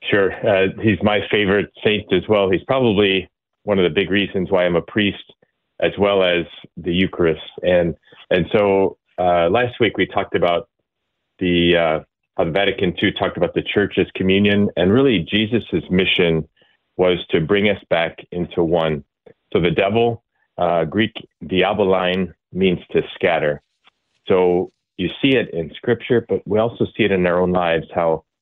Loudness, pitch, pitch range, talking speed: -18 LUFS, 95 Hz, 85-100 Hz, 170 wpm